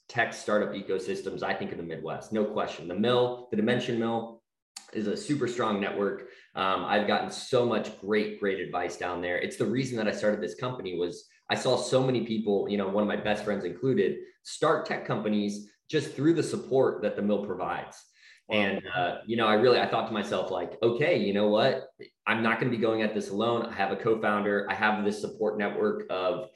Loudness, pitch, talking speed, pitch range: -28 LUFS, 105 Hz, 220 wpm, 100-120 Hz